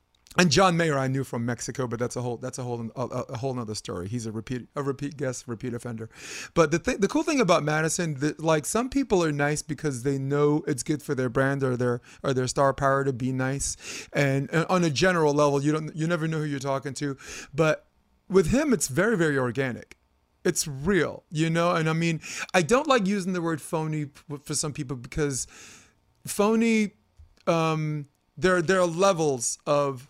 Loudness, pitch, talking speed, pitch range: -26 LUFS, 145 Hz, 200 wpm, 130-165 Hz